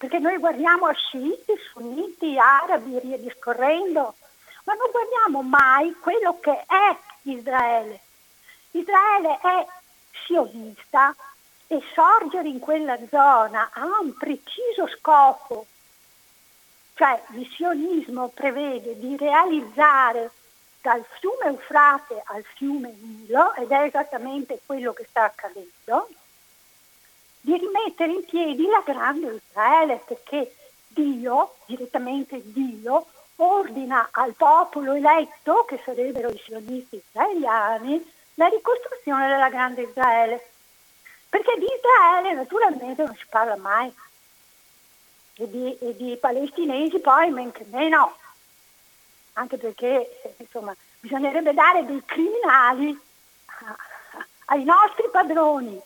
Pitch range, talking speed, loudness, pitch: 250-340 Hz, 105 wpm, -21 LUFS, 280 Hz